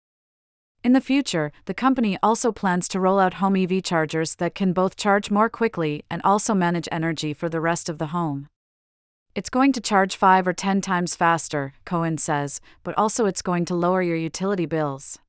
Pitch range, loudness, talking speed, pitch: 165-200 Hz, -22 LUFS, 190 wpm, 180 Hz